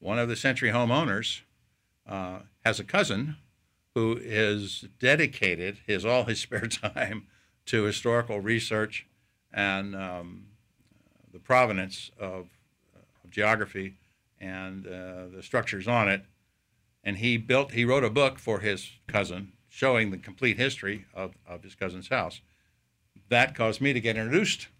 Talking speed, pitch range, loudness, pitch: 140 wpm, 95-120 Hz, -27 LUFS, 105 Hz